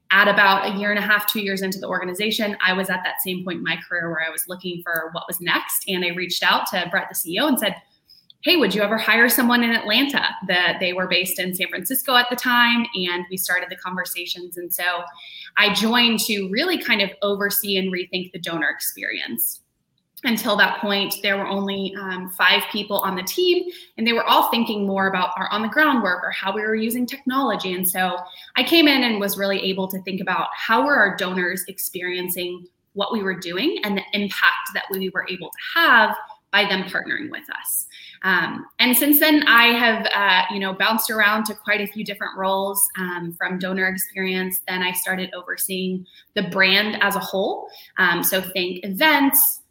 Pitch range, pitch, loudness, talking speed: 185-225 Hz, 195 Hz, -20 LUFS, 210 wpm